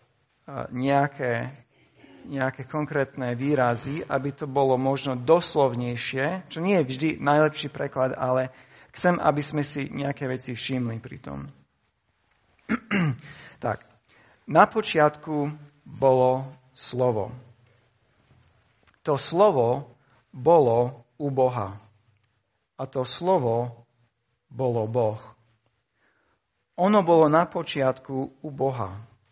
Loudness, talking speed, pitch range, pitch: -25 LUFS, 95 wpm, 120-145 Hz, 130 Hz